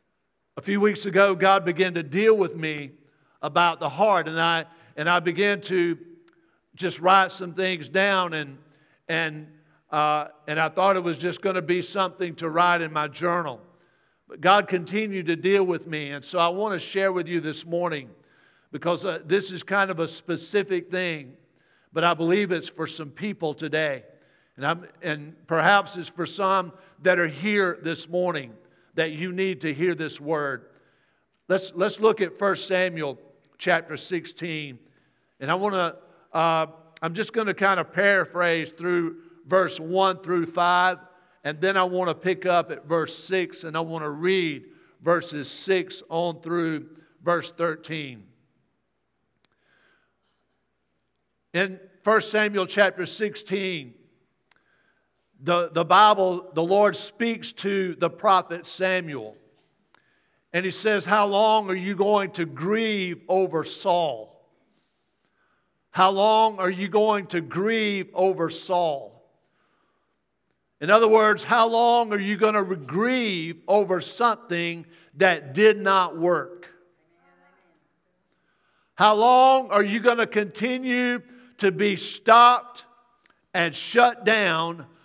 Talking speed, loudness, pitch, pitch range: 145 wpm, -23 LUFS, 180 Hz, 165-195 Hz